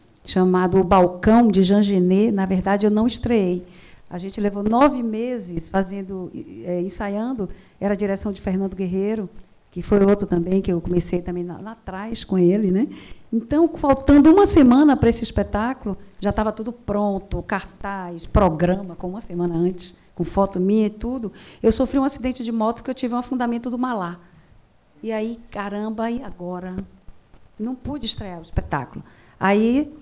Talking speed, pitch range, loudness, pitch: 170 wpm, 185-230 Hz, -21 LUFS, 200 Hz